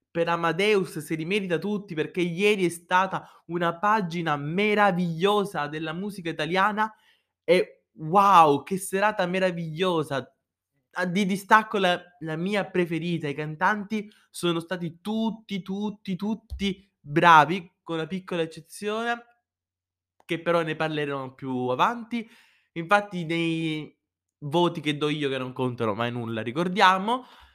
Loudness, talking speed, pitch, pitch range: -25 LUFS, 125 wpm, 175 Hz, 155-200 Hz